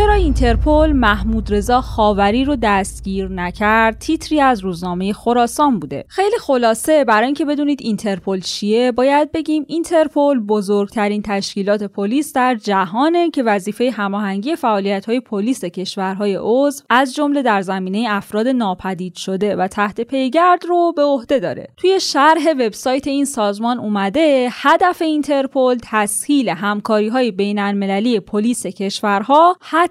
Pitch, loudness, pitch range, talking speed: 230 Hz, -16 LUFS, 205-285 Hz, 125 wpm